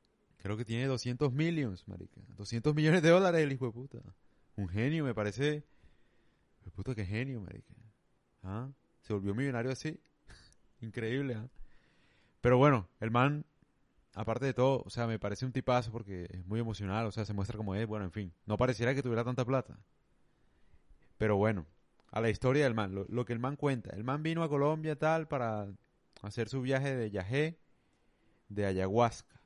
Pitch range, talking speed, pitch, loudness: 105-135 Hz, 180 wpm, 120 Hz, -33 LUFS